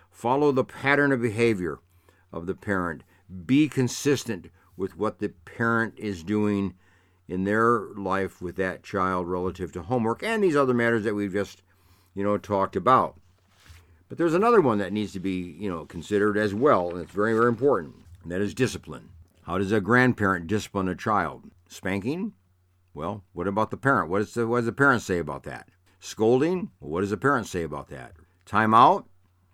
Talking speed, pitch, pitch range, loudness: 185 wpm, 100 Hz, 90-115 Hz, -25 LUFS